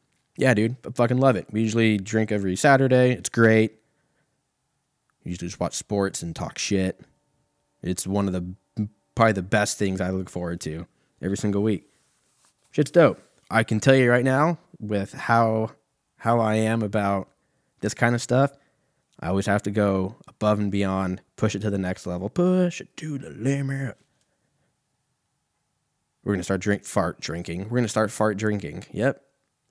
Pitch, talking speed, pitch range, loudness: 110 Hz, 170 wpm, 100-130 Hz, -24 LUFS